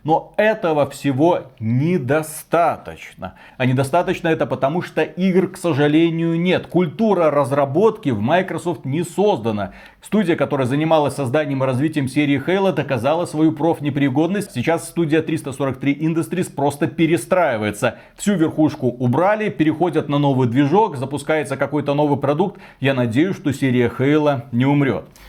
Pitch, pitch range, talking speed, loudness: 155 Hz, 140-170 Hz, 130 wpm, -19 LUFS